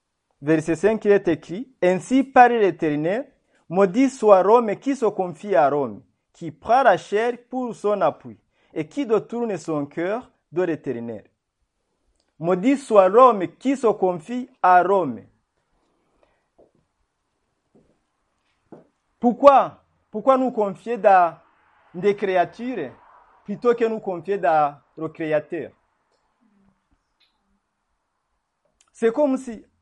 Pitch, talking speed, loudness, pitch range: 200 Hz, 115 wpm, -20 LUFS, 170-240 Hz